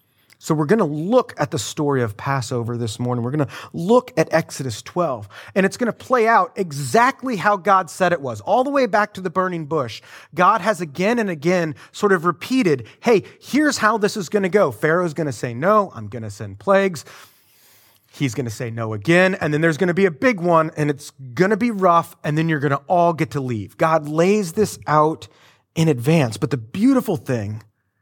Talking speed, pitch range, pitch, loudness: 225 wpm, 130-195 Hz, 160 Hz, -19 LUFS